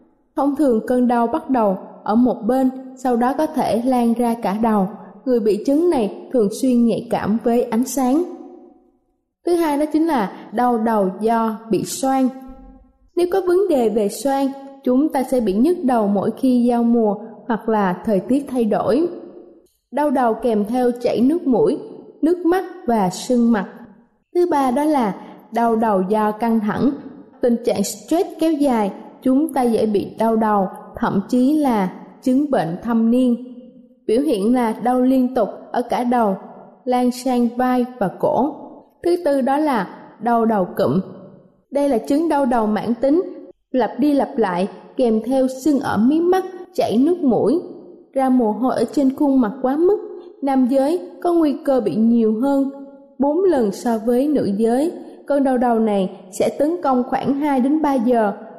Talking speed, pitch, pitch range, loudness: 180 wpm, 250 Hz, 225-280 Hz, -19 LUFS